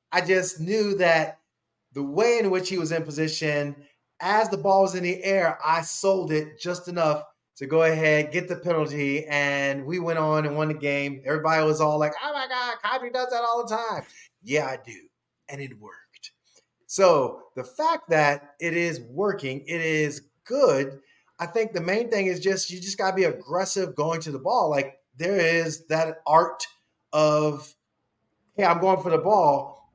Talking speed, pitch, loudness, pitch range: 195 wpm, 165 Hz, -24 LUFS, 150-195 Hz